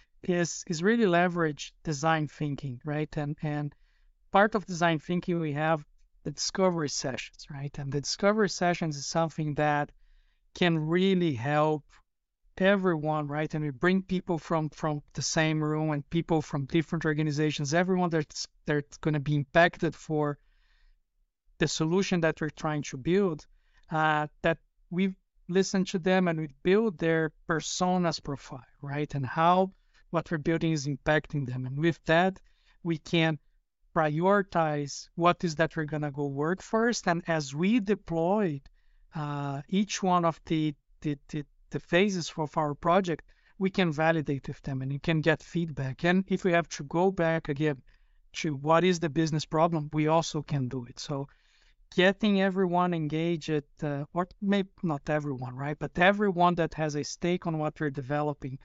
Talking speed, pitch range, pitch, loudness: 165 wpm, 150-175 Hz, 160 Hz, -29 LUFS